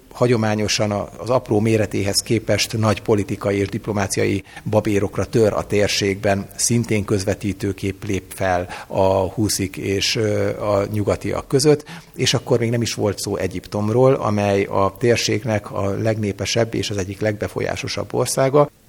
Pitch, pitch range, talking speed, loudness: 105 Hz, 100-115 Hz, 130 wpm, -20 LUFS